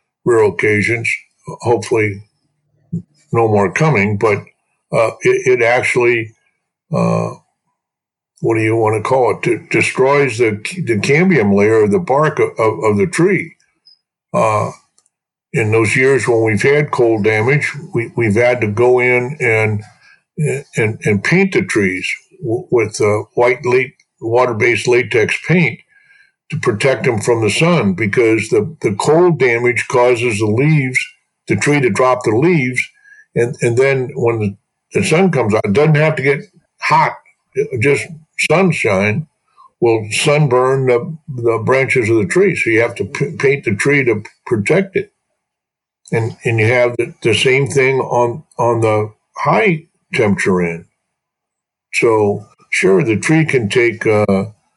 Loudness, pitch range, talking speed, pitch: -14 LUFS, 110-165 Hz, 150 wpm, 130 Hz